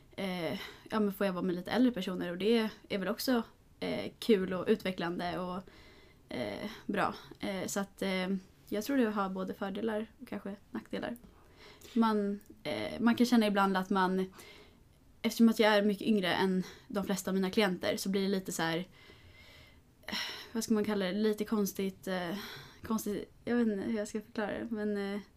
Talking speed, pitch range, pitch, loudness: 190 wpm, 190-220 Hz, 205 Hz, -33 LUFS